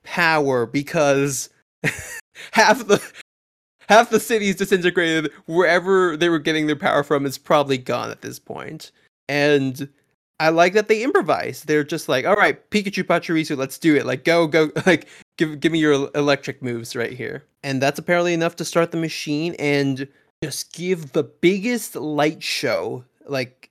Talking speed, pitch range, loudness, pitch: 165 wpm, 140-175 Hz, -20 LUFS, 160 Hz